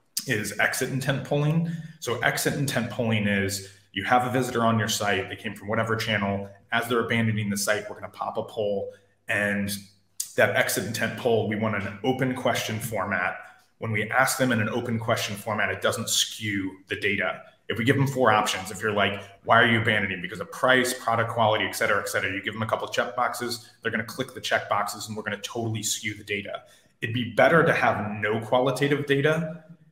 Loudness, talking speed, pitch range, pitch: -25 LUFS, 215 wpm, 105-130 Hz, 115 Hz